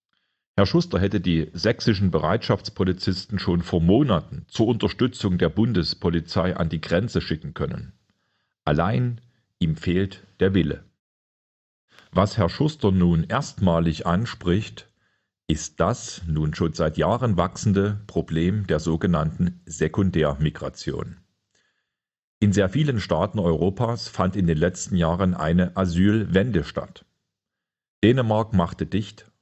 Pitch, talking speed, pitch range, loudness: 95 Hz, 115 wpm, 85-105 Hz, -23 LUFS